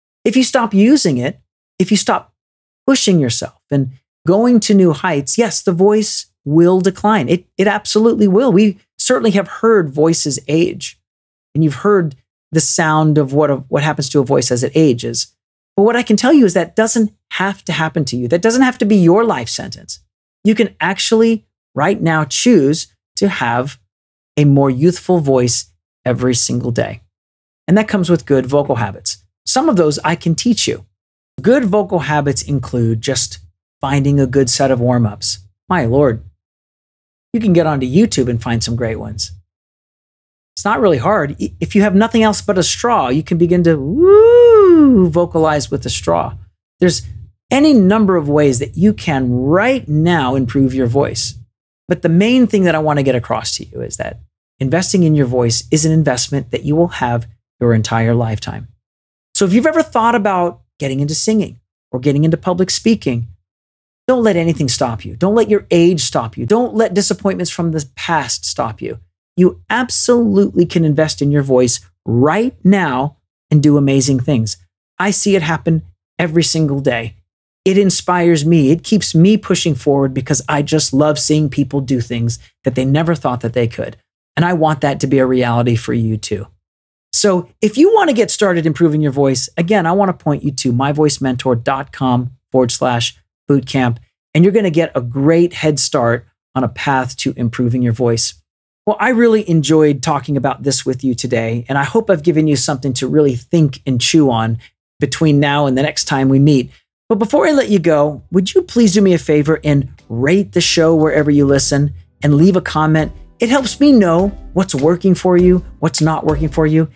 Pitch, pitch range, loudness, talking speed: 150 Hz, 125-185 Hz, -14 LUFS, 190 wpm